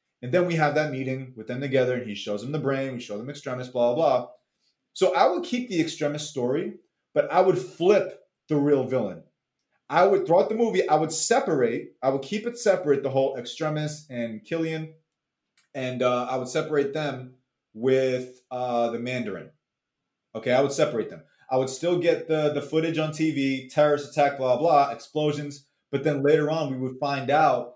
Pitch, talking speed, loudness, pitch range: 145 Hz, 195 wpm, -25 LUFS, 130-160 Hz